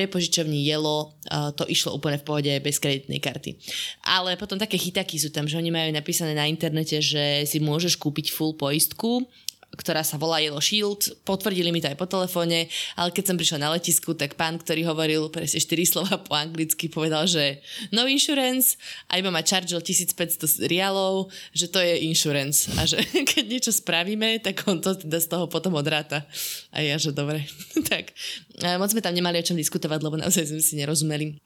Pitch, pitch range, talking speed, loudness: 165 Hz, 155-185 Hz, 185 wpm, -24 LUFS